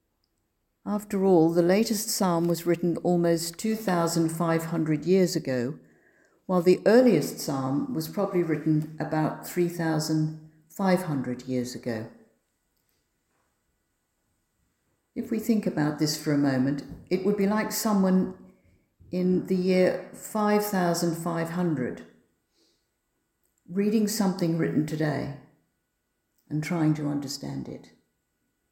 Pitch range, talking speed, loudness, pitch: 150-185 Hz, 100 wpm, -26 LUFS, 170 Hz